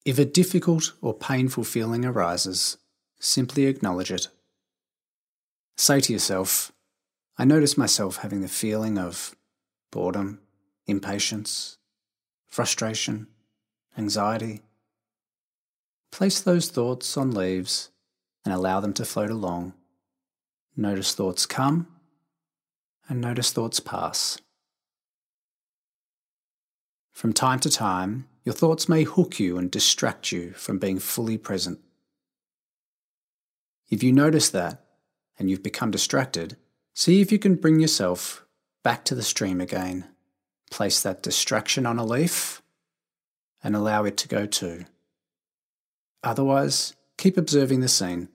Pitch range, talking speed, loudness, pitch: 95-130 Hz, 115 wpm, -24 LUFS, 105 Hz